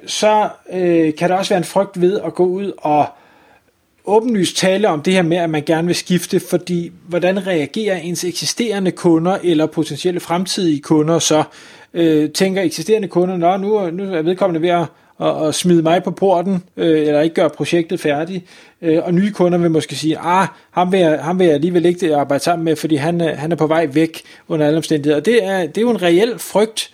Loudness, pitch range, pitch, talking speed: -16 LUFS, 160-185 Hz, 175 Hz, 215 wpm